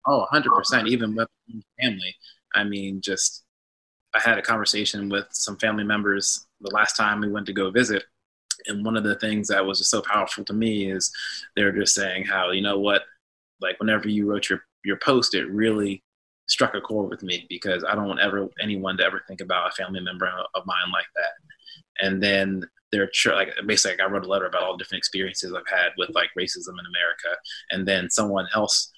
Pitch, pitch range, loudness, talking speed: 100 Hz, 95-105 Hz, -23 LUFS, 215 wpm